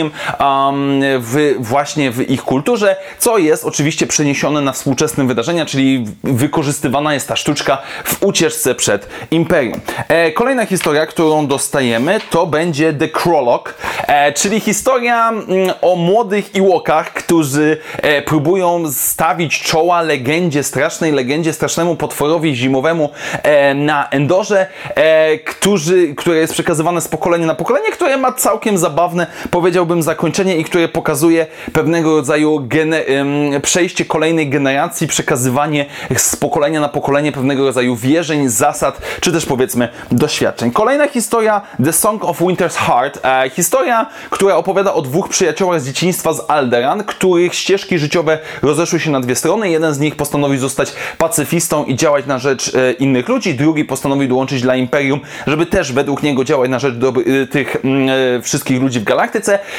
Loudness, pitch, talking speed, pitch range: -14 LUFS, 155 Hz, 150 wpm, 140-175 Hz